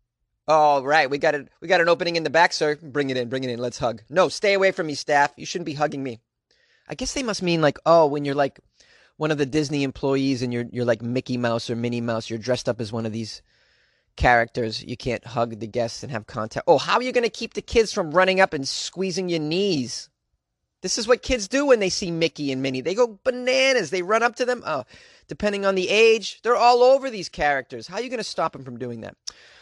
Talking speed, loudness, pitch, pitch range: 255 wpm, -22 LUFS, 155 Hz, 125-200 Hz